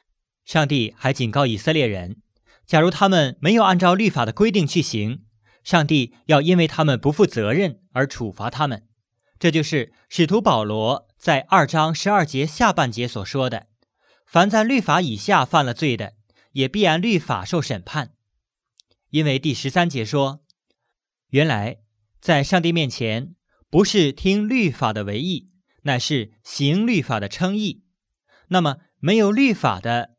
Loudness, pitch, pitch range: -20 LUFS, 150 Hz, 120-180 Hz